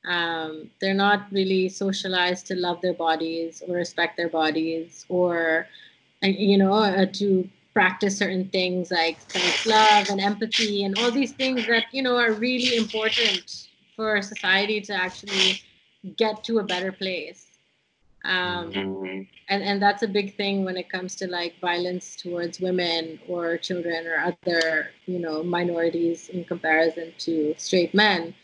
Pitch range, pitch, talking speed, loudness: 170-205 Hz, 185 Hz, 150 wpm, -24 LUFS